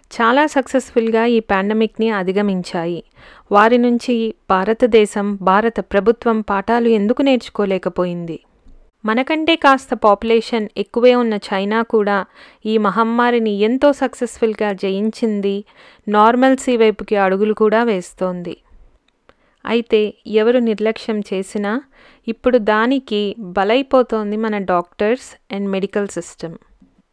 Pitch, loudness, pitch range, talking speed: 220 Hz, -16 LUFS, 200-240 Hz, 95 wpm